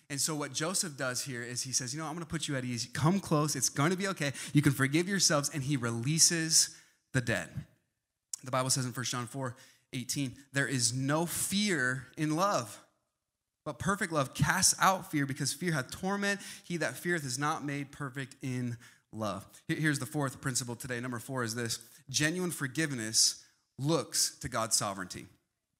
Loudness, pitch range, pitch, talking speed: -31 LUFS, 125-160 Hz, 140 Hz, 190 wpm